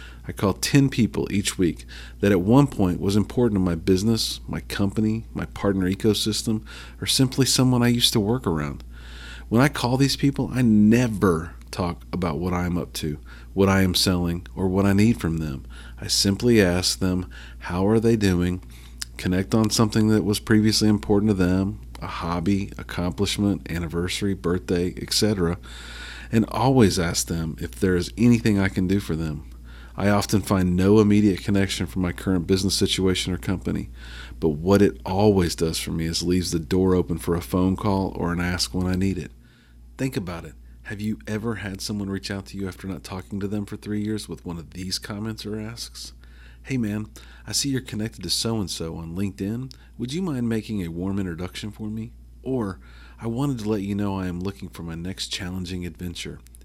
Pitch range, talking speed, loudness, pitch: 85-105 Hz, 195 wpm, -23 LUFS, 95 Hz